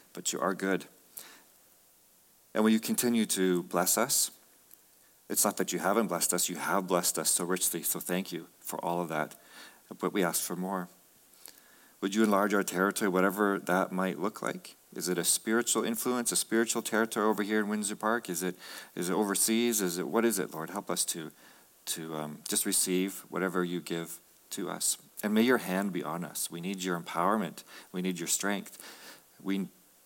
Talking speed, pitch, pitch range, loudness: 195 wpm, 95 Hz, 90-105 Hz, -30 LUFS